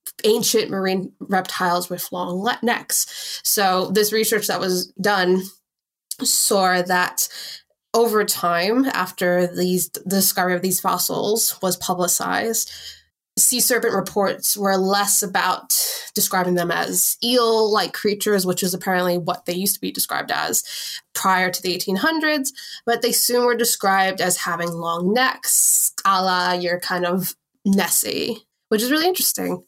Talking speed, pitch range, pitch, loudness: 140 wpm, 180-230 Hz, 195 Hz, -19 LUFS